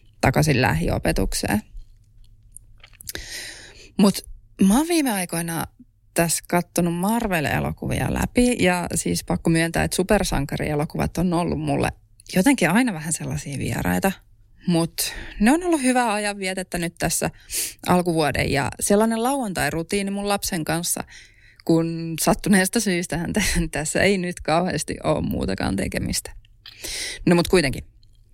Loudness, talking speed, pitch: -22 LUFS, 115 wpm, 170 Hz